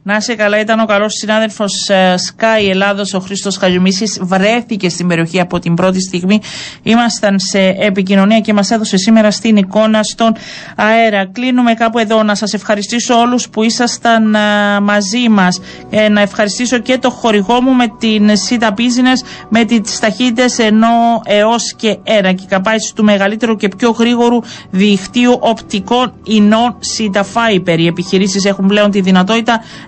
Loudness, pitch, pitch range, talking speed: -11 LUFS, 215 Hz, 200-230 Hz, 160 wpm